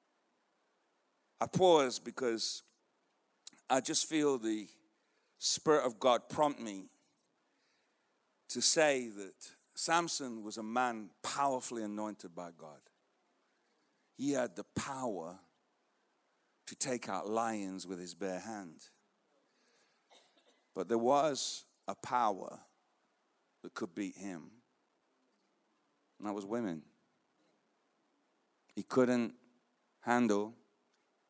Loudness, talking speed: -34 LUFS, 100 wpm